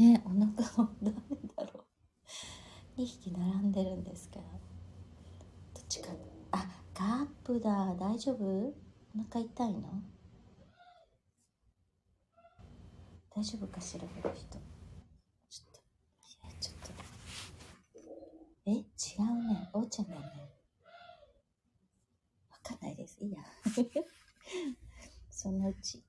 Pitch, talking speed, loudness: 200 Hz, 190 characters per minute, -37 LUFS